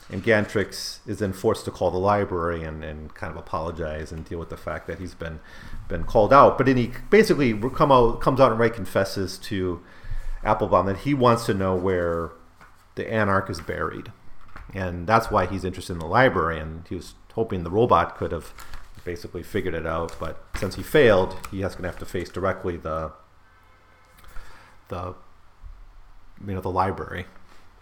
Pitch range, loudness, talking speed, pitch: 85-105 Hz, -23 LUFS, 185 wpm, 95 Hz